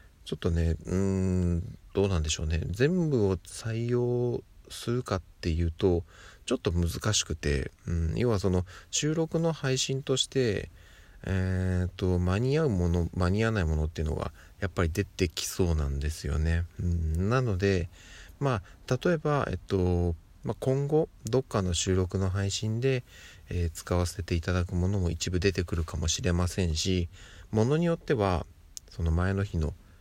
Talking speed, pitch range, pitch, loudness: 315 characters per minute, 85-110 Hz, 95 Hz, -29 LUFS